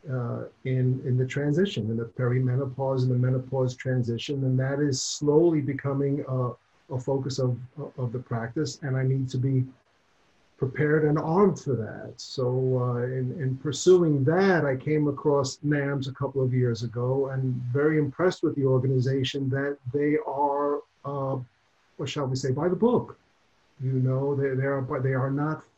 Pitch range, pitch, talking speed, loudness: 130-145 Hz, 135 Hz, 170 wpm, -26 LUFS